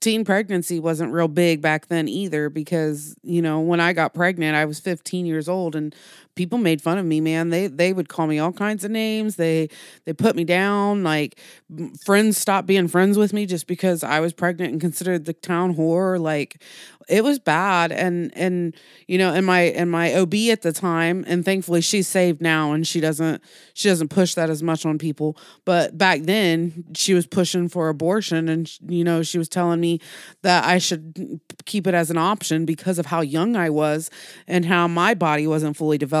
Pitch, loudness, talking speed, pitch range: 170 Hz, -21 LUFS, 210 wpm, 160-185 Hz